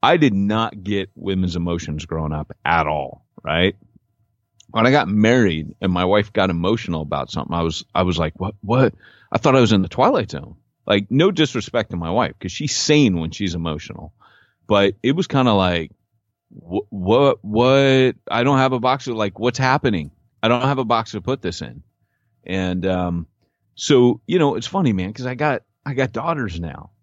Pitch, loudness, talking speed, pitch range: 105 Hz, -19 LUFS, 200 wpm, 90-125 Hz